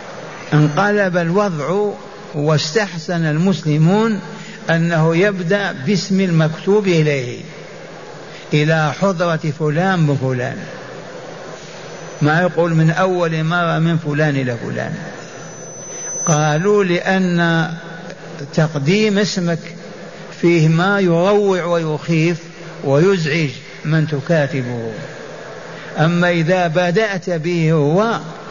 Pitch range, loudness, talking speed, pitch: 155-190 Hz, -16 LUFS, 80 wpm, 170 Hz